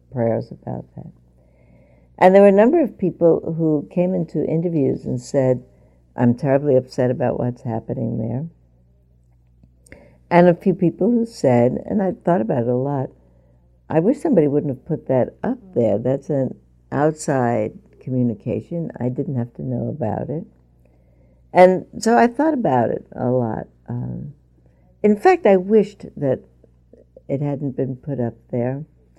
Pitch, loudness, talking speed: 130 Hz, -19 LUFS, 155 wpm